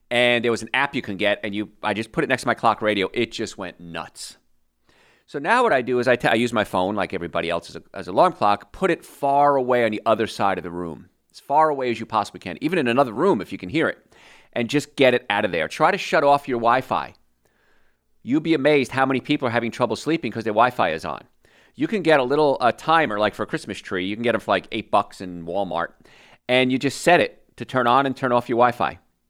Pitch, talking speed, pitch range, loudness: 115 Hz, 275 wpm, 100-130 Hz, -21 LUFS